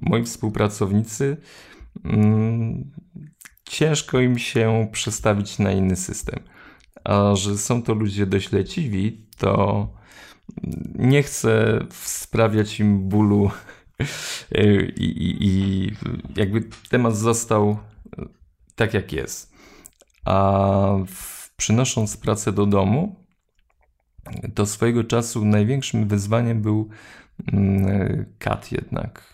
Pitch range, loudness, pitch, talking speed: 100-115 Hz, -21 LUFS, 105 Hz, 90 wpm